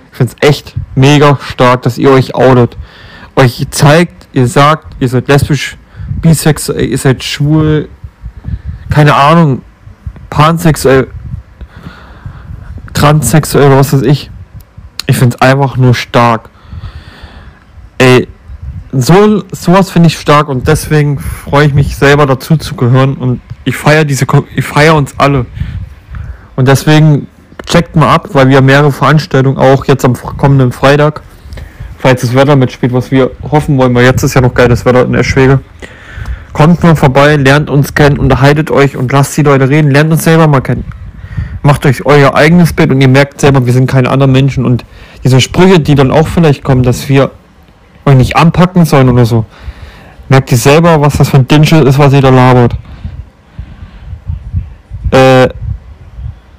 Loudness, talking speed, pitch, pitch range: -7 LUFS, 160 wpm, 135 Hz, 110-145 Hz